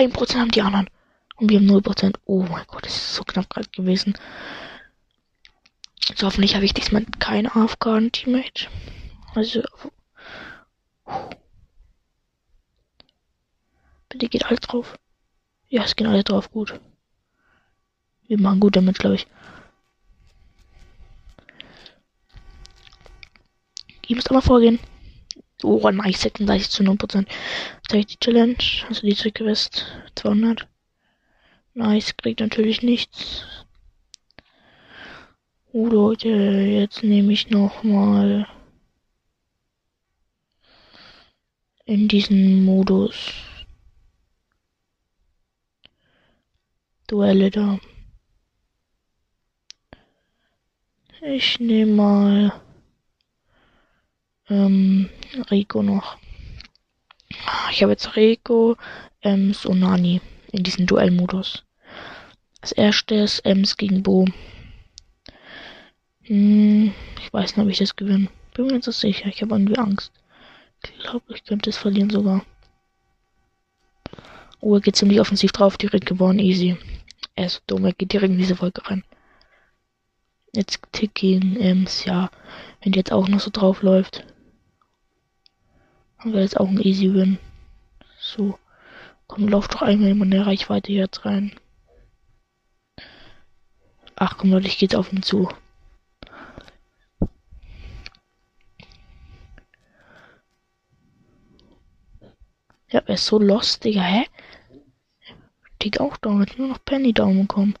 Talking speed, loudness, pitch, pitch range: 110 wpm, -20 LUFS, 200 Hz, 185-215 Hz